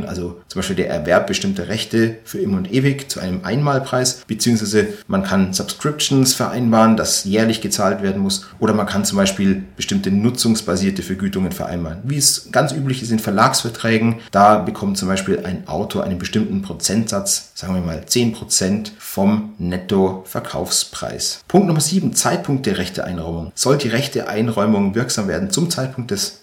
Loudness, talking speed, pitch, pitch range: -18 LUFS, 155 wpm, 115 Hz, 100-150 Hz